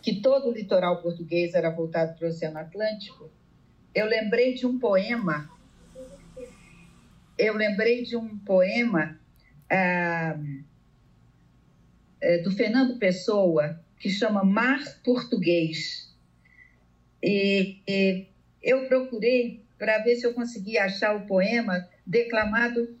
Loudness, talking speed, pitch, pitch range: -25 LUFS, 110 wpm, 195 Hz, 170-235 Hz